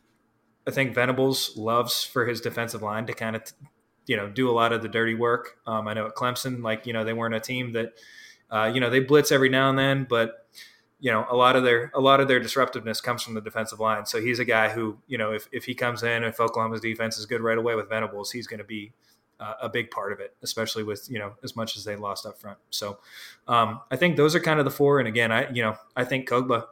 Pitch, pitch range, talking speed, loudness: 115 Hz, 110-125 Hz, 265 wpm, -25 LUFS